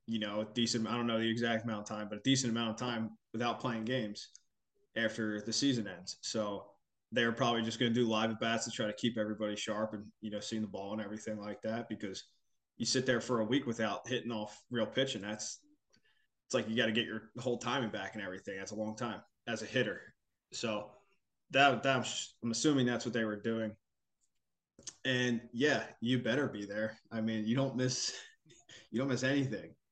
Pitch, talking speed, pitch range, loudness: 115 Hz, 215 wpm, 110-125 Hz, -35 LUFS